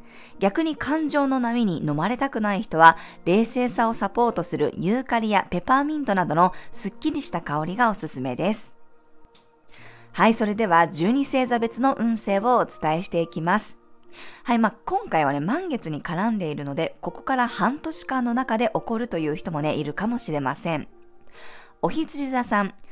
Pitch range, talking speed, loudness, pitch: 165-245 Hz, 340 characters per minute, -23 LUFS, 215 Hz